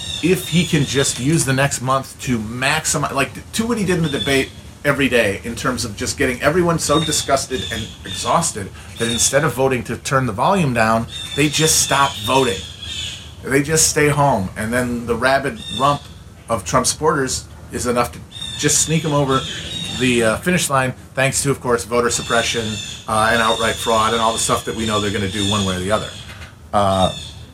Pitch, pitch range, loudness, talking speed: 120 Hz, 105-140 Hz, -18 LUFS, 205 wpm